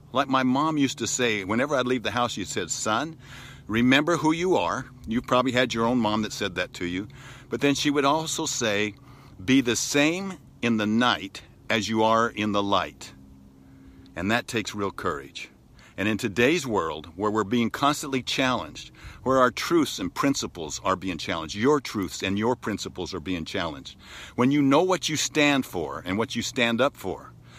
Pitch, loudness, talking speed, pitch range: 115 Hz, -25 LUFS, 195 wpm, 100-130 Hz